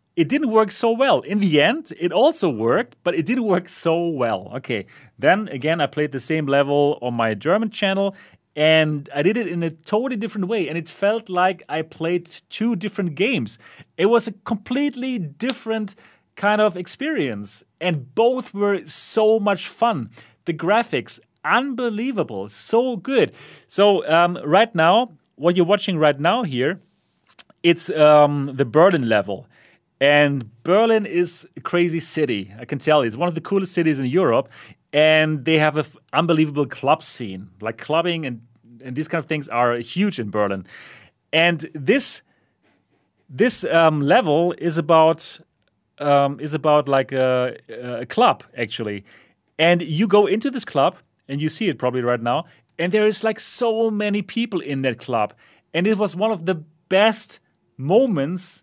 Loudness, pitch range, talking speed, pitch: -20 LUFS, 145-205 Hz, 170 wpm, 170 Hz